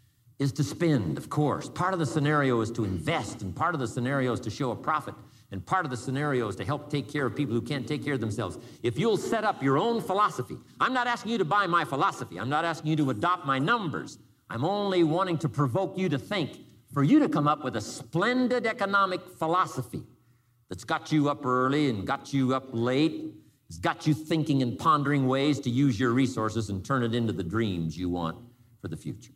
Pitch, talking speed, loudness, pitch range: 140 Hz, 230 wpm, -28 LUFS, 120-160 Hz